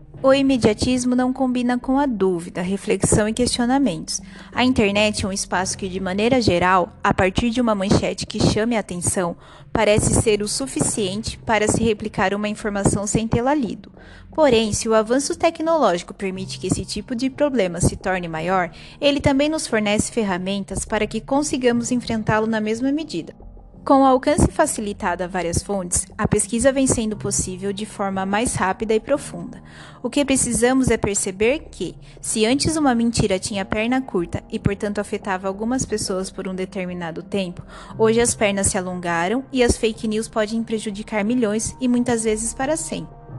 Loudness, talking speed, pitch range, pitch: -20 LUFS, 170 wpm, 195-250 Hz, 220 Hz